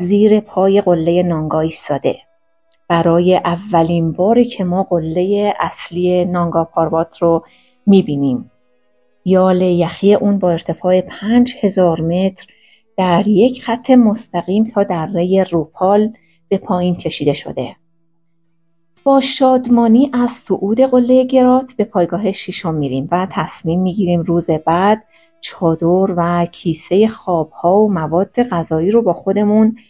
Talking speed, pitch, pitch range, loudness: 120 wpm, 185 Hz, 170-215 Hz, -15 LUFS